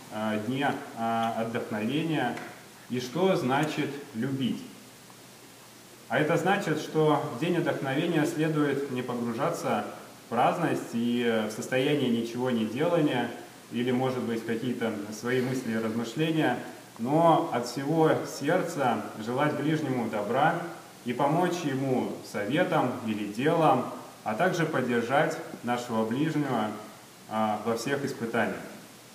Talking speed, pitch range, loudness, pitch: 110 wpm, 115-150 Hz, -28 LUFS, 125 Hz